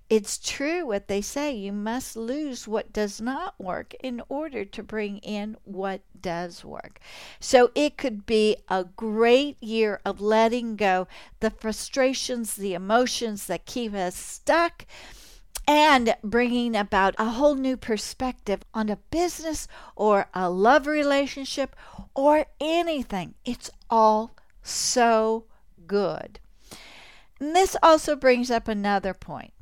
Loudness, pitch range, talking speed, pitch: -24 LUFS, 205-270 Hz, 130 wpm, 225 Hz